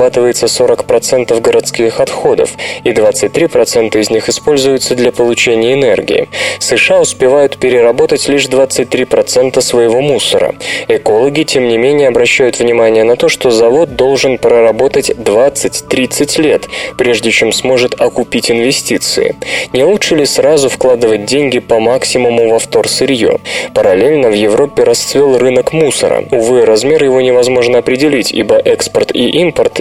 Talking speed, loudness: 125 wpm, -9 LUFS